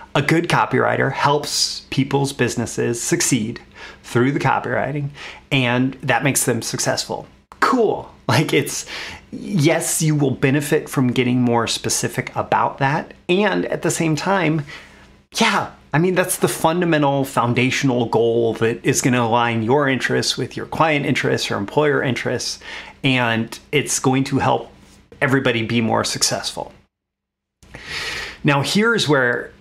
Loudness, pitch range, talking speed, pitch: -19 LUFS, 120-160 Hz, 135 wpm, 135 Hz